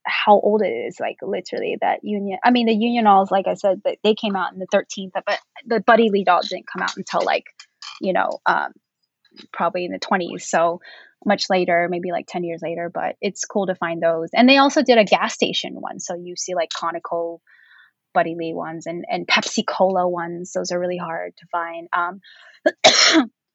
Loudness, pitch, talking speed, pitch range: -20 LUFS, 190 Hz, 210 wpm, 175-225 Hz